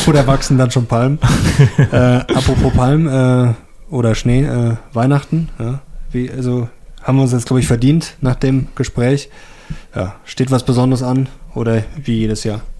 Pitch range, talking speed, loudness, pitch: 125-140 Hz, 165 wpm, -15 LUFS, 130 Hz